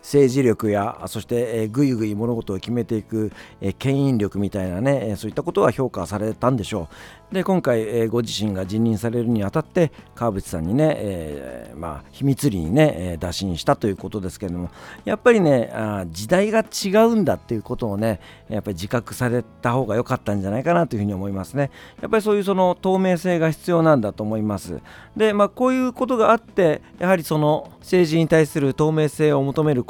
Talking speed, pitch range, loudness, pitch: 400 characters per minute, 105-155 Hz, -21 LUFS, 120 Hz